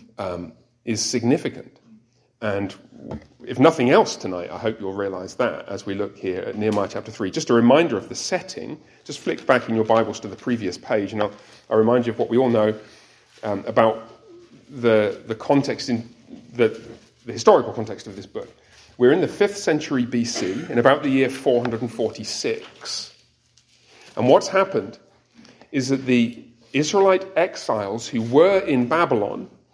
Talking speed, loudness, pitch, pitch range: 165 wpm, -21 LUFS, 120 Hz, 110-135 Hz